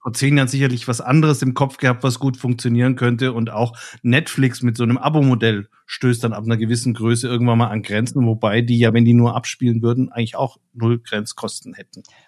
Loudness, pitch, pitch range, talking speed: -18 LUFS, 120 Hz, 115-130 Hz, 210 wpm